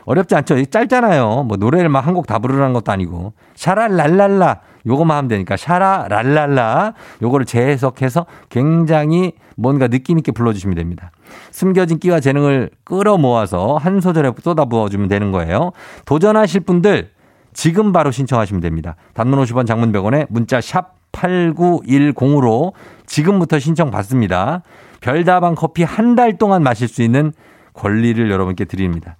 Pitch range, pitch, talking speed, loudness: 115-175 Hz, 140 Hz, 335 characters per minute, -15 LUFS